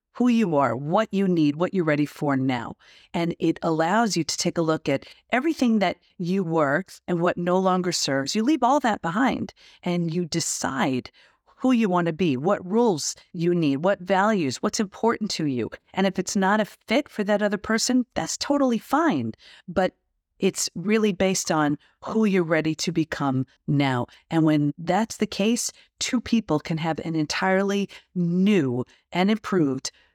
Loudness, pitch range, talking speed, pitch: -24 LUFS, 160-215 Hz, 180 wpm, 185 Hz